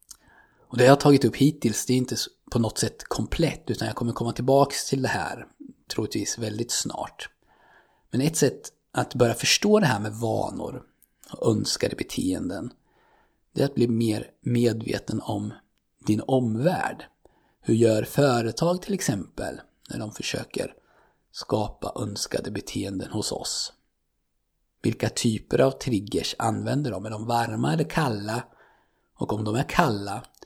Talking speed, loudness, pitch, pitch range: 150 wpm, -25 LUFS, 120 Hz, 110-140 Hz